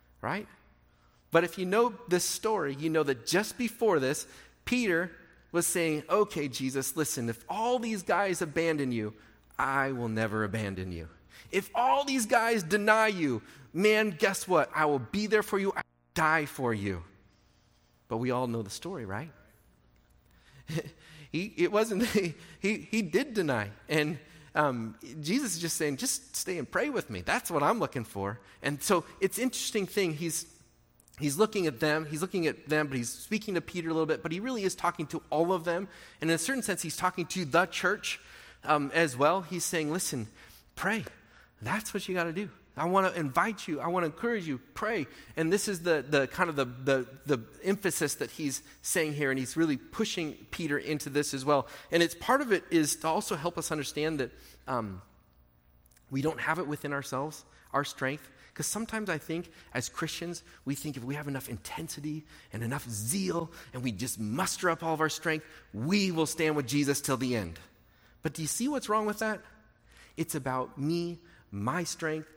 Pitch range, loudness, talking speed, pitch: 135-185 Hz, -31 LUFS, 195 wpm, 155 Hz